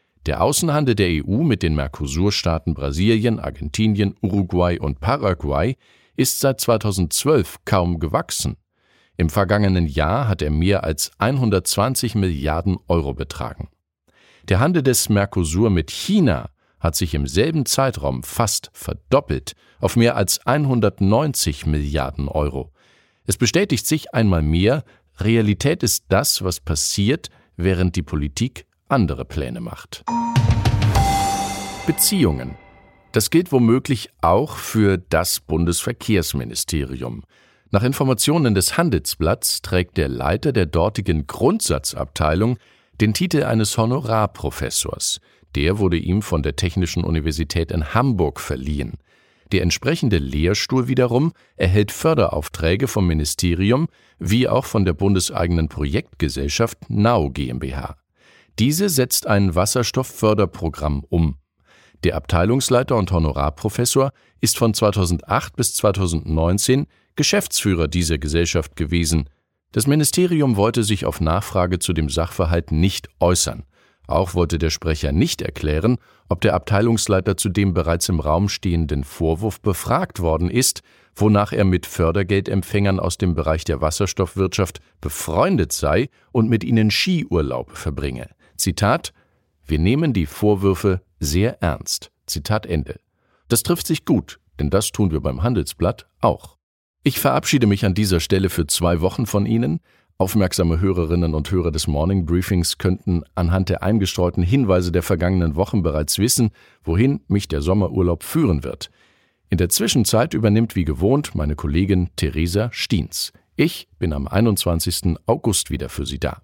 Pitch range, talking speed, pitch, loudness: 80-110 Hz, 130 wpm, 95 Hz, -20 LUFS